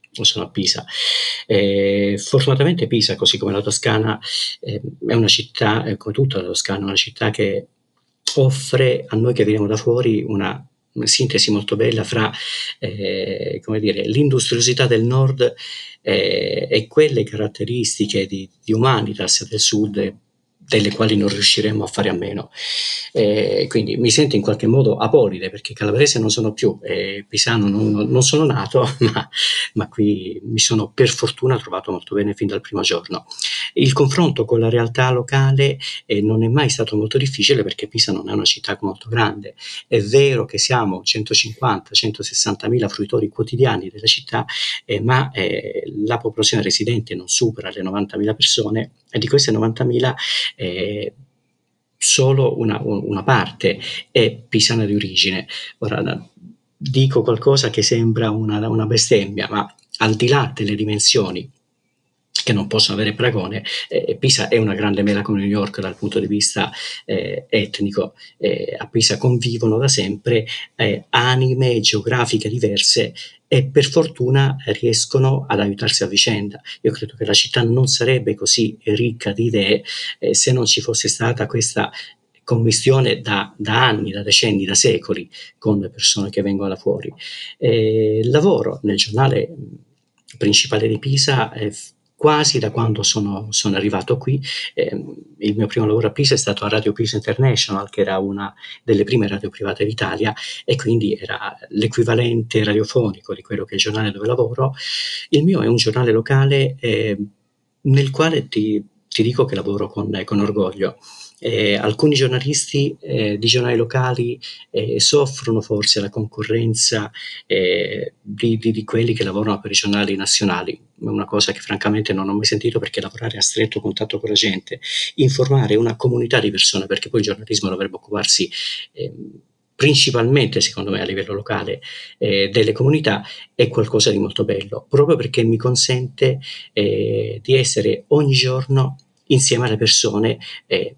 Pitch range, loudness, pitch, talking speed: 105-130 Hz, -17 LUFS, 115 Hz, 160 wpm